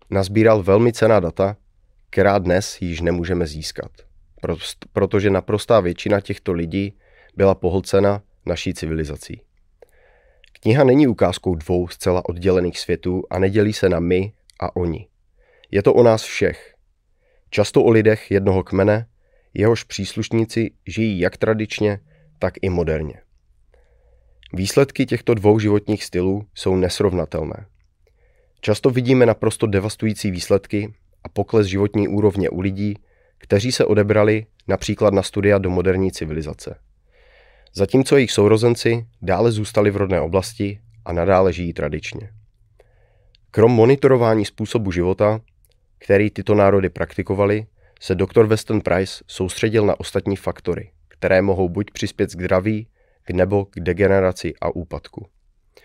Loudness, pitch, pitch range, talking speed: -19 LUFS, 100 Hz, 90-110 Hz, 125 wpm